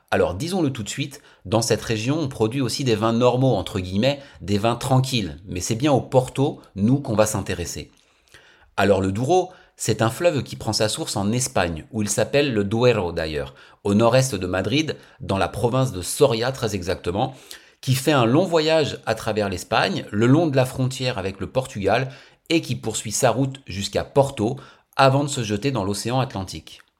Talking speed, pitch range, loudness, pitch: 195 wpm, 105-135 Hz, -22 LUFS, 120 Hz